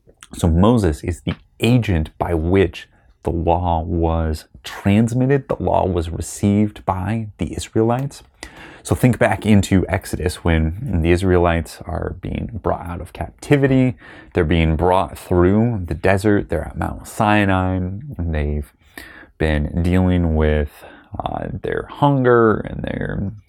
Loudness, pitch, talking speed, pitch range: -19 LUFS, 90 Hz, 135 wpm, 85-105 Hz